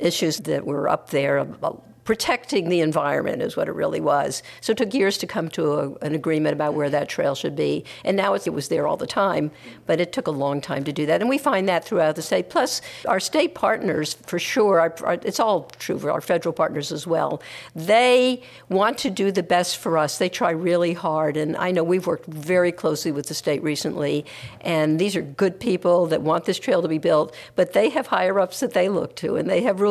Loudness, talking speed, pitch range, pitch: -22 LUFS, 240 wpm, 155-195 Hz, 165 Hz